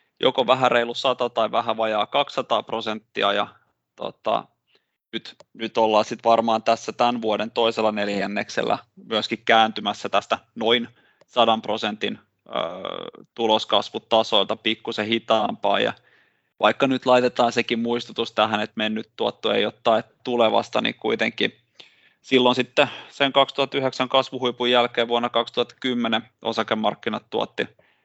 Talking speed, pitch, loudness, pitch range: 120 wpm, 115 Hz, -22 LUFS, 110-125 Hz